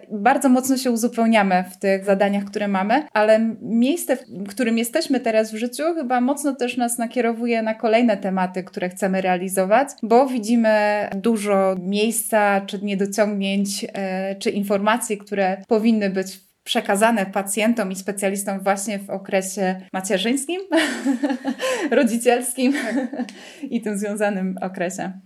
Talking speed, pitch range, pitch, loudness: 125 wpm, 195-245 Hz, 215 Hz, -21 LUFS